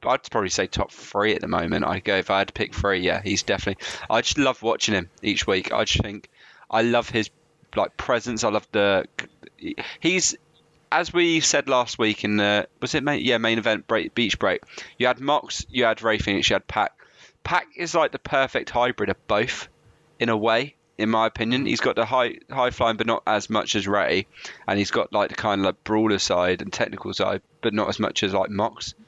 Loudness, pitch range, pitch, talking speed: -23 LUFS, 105-130 Hz, 115 Hz, 230 wpm